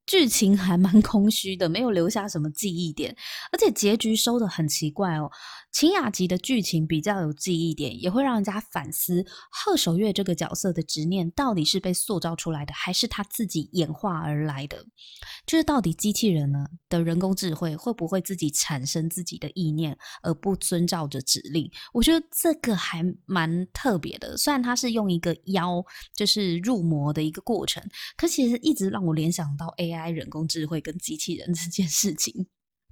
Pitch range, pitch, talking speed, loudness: 165-215 Hz, 180 Hz, 285 characters per minute, -25 LUFS